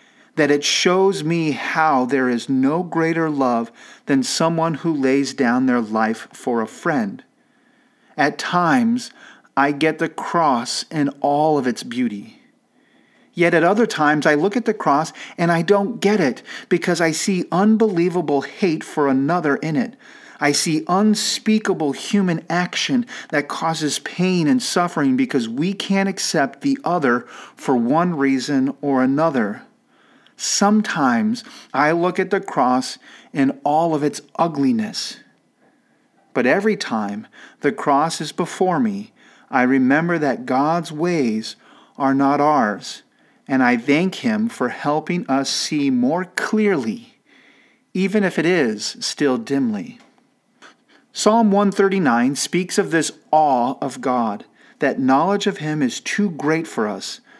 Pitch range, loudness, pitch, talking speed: 145-215 Hz, -19 LUFS, 170 Hz, 140 wpm